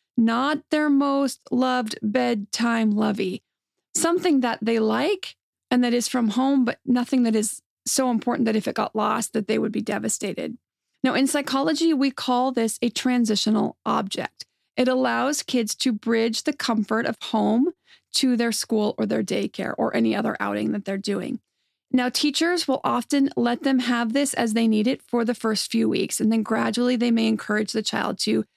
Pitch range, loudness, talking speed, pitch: 220-265 Hz, -23 LUFS, 185 wpm, 240 Hz